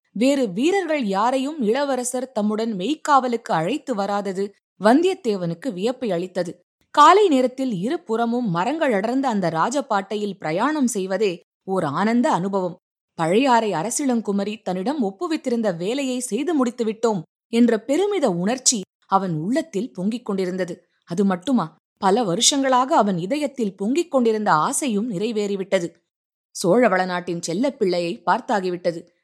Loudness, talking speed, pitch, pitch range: -21 LUFS, 105 wpm, 220 Hz, 190-260 Hz